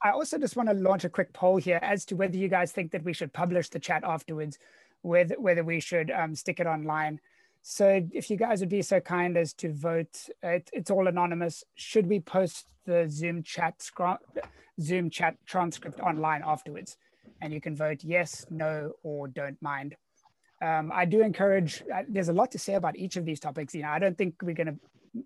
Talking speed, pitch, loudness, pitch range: 215 wpm, 175 Hz, -29 LUFS, 160-190 Hz